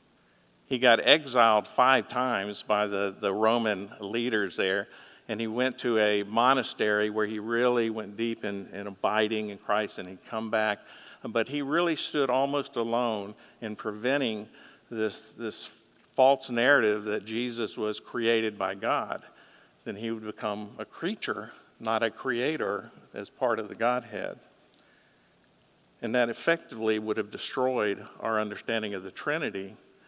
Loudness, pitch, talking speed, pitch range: -28 LUFS, 110 Hz, 150 wpm, 105-120 Hz